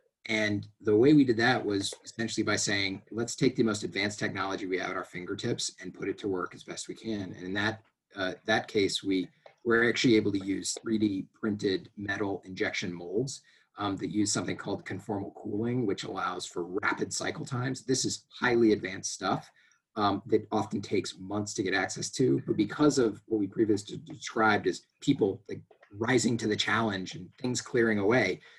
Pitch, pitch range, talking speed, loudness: 110 Hz, 100-115 Hz, 195 wpm, -30 LUFS